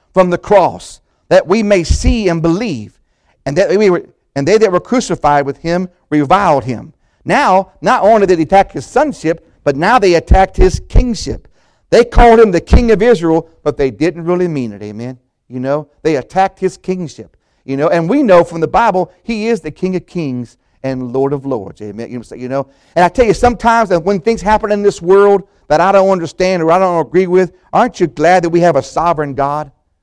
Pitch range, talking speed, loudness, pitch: 145-195 Hz, 210 wpm, -12 LUFS, 175 Hz